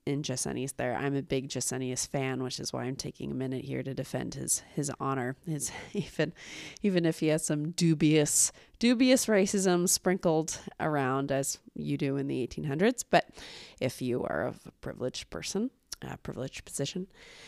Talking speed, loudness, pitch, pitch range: 170 wpm, -30 LUFS, 145 Hz, 130-175 Hz